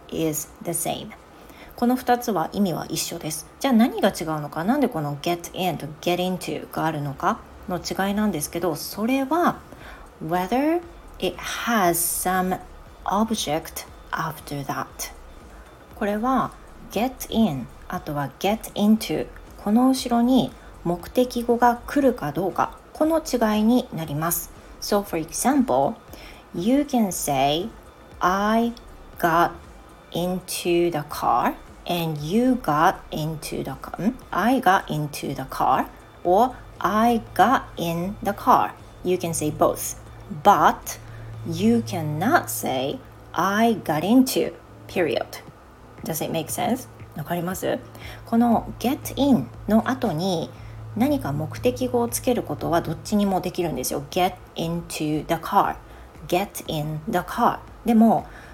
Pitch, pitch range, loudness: 185 Hz, 165-235 Hz, -23 LUFS